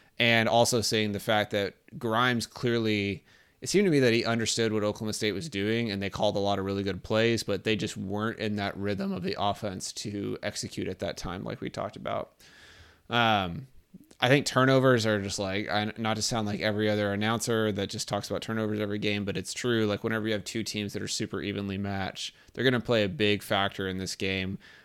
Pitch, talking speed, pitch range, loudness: 105 Hz, 225 wpm, 100-115 Hz, -28 LUFS